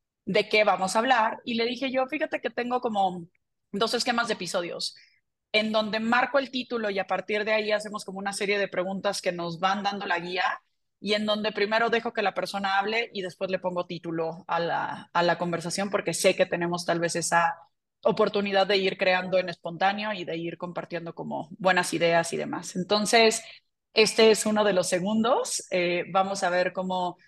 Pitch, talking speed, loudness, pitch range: 195 Hz, 200 wpm, -26 LUFS, 180-215 Hz